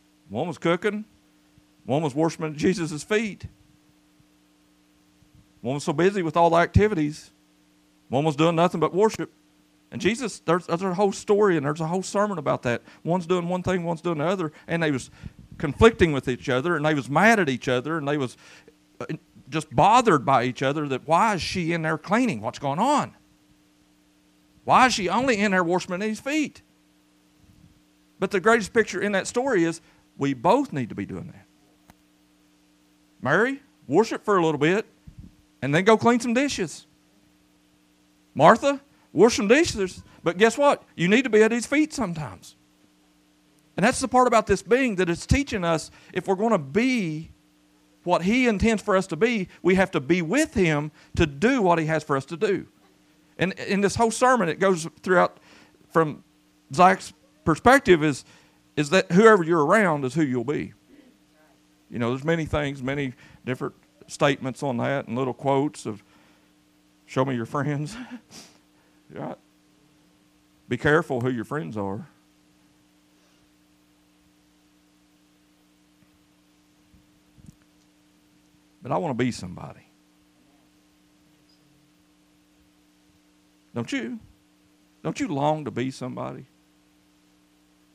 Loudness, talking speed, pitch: -23 LUFS, 155 wpm, 140 Hz